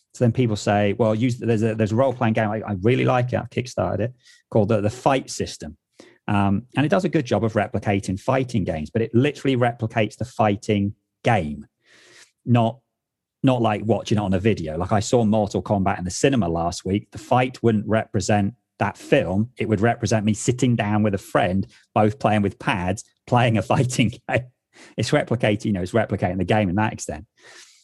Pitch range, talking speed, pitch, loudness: 105-120 Hz, 205 wpm, 110 Hz, -22 LUFS